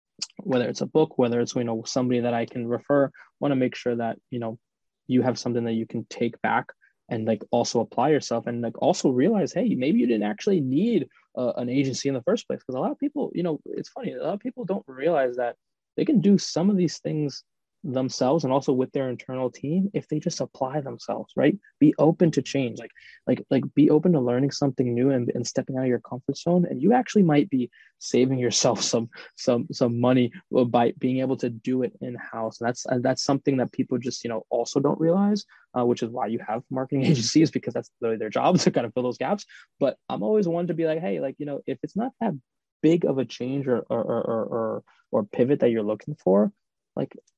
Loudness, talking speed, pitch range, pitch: -25 LUFS, 235 wpm, 120-150 Hz, 130 Hz